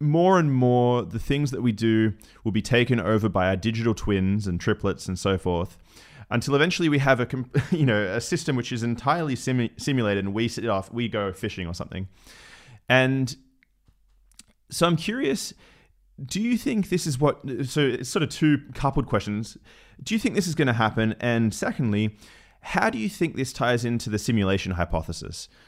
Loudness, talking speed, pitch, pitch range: -24 LUFS, 190 wpm, 120 Hz, 105-140 Hz